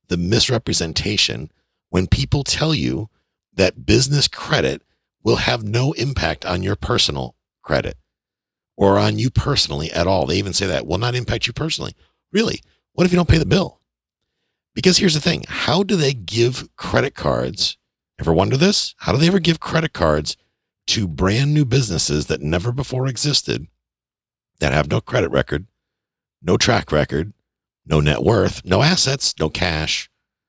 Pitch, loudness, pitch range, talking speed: 110 Hz, -19 LUFS, 85-140 Hz, 165 wpm